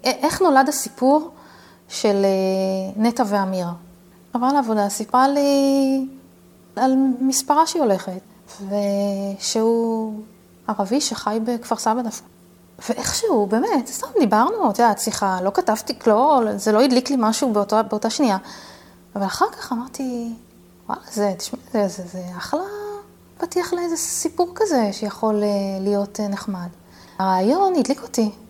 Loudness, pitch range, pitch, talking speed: -20 LUFS, 200-270 Hz, 225 Hz, 125 wpm